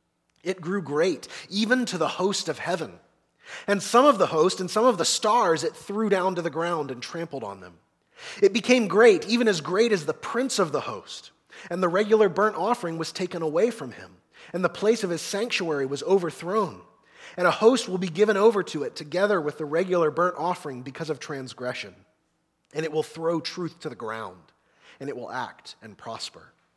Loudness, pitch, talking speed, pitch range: -24 LUFS, 175 Hz, 205 wpm, 155-205 Hz